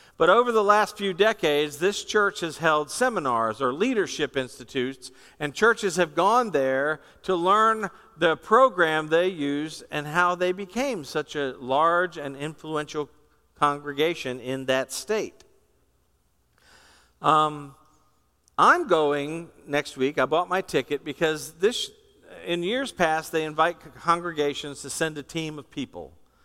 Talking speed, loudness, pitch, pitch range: 140 wpm, -24 LUFS, 155 Hz, 145-190 Hz